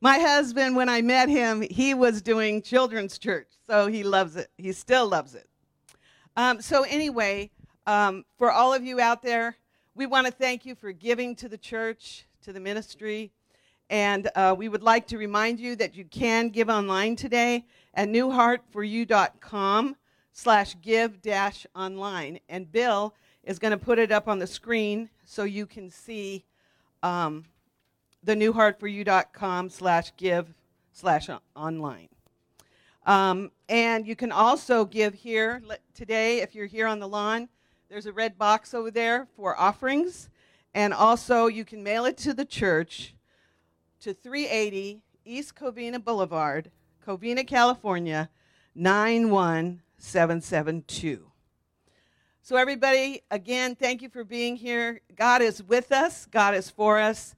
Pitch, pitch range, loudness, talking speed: 220 Hz, 195-240 Hz, -25 LUFS, 140 wpm